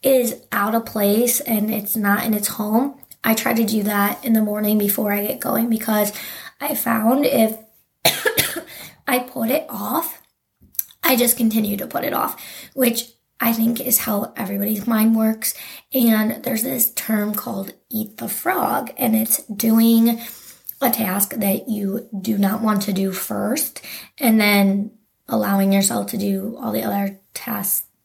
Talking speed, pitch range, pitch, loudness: 165 wpm, 210-240 Hz, 220 Hz, -20 LUFS